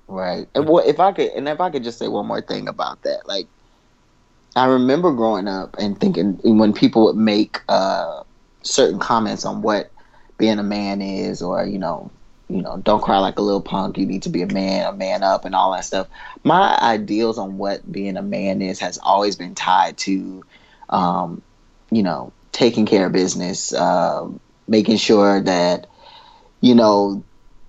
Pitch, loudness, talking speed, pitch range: 100 Hz, -19 LUFS, 190 wpm, 95-110 Hz